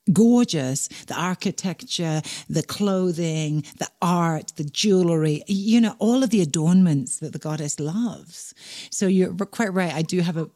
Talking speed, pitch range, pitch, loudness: 155 wpm, 155-200 Hz, 175 Hz, -22 LUFS